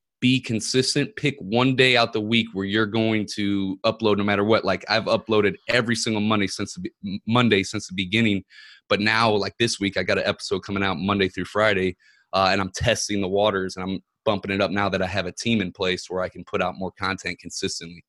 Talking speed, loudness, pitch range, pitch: 225 wpm, -23 LUFS, 95-115 Hz, 100 Hz